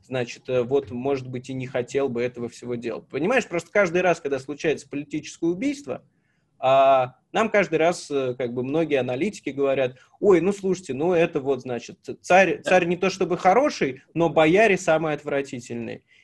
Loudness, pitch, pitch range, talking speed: -23 LUFS, 145 Hz, 130-175 Hz, 165 wpm